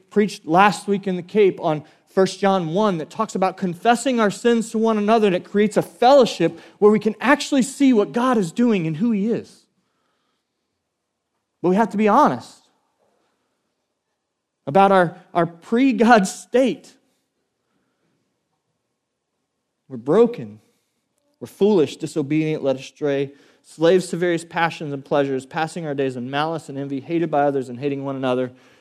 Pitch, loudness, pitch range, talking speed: 185 Hz, -19 LUFS, 155-220 Hz, 160 wpm